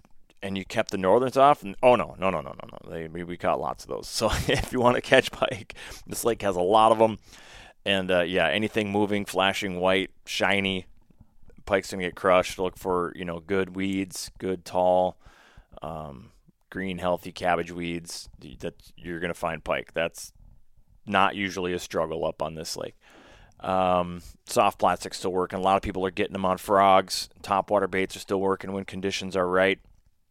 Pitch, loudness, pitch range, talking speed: 95 Hz, -25 LUFS, 90-100 Hz, 190 wpm